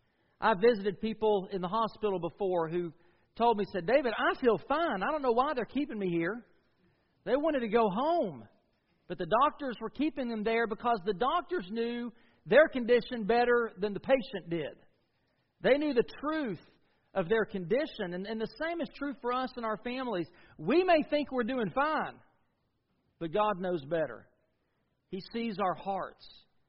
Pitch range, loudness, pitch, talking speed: 185-255 Hz, -31 LUFS, 220 Hz, 175 wpm